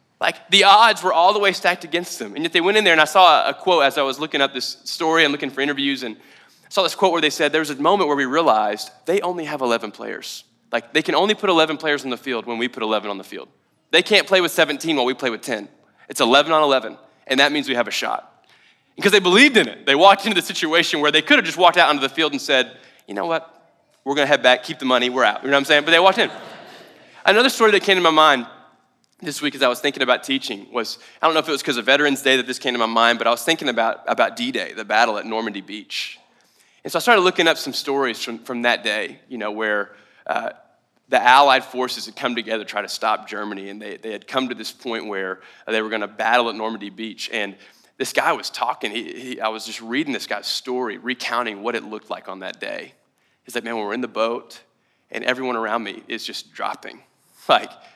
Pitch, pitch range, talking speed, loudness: 135 Hz, 115-160 Hz, 270 wpm, -18 LUFS